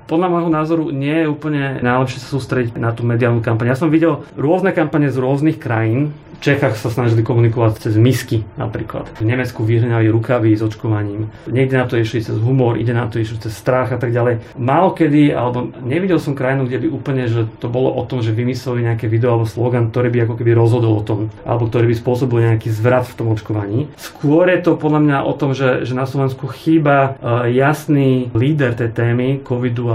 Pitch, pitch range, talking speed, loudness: 125 Hz, 115-140 Hz, 205 wpm, -16 LUFS